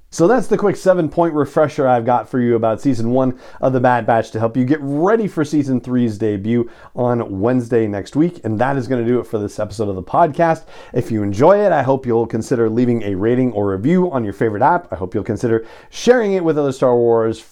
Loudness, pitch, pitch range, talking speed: -17 LUFS, 125 Hz, 115-150 Hz, 245 wpm